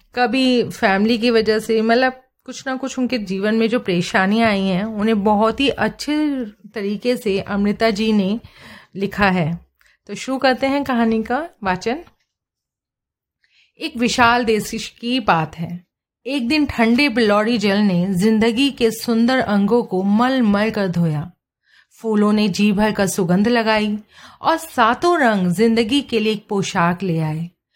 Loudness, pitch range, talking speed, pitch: -18 LUFS, 200-245 Hz, 155 wpm, 220 Hz